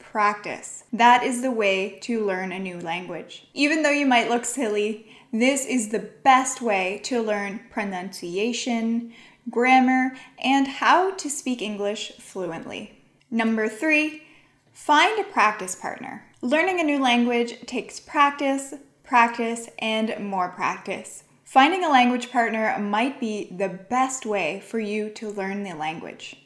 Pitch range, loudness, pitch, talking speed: 210-260 Hz, -23 LUFS, 235 Hz, 140 wpm